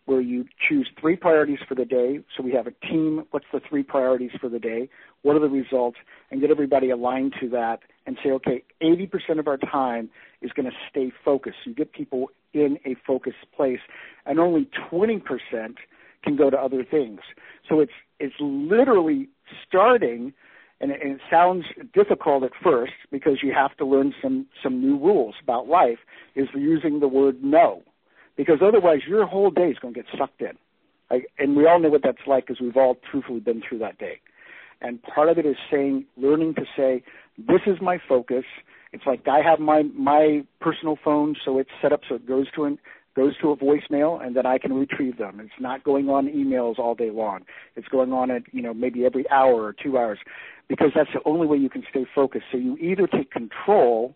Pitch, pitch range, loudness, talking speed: 140 Hz, 130-155 Hz, -22 LUFS, 205 wpm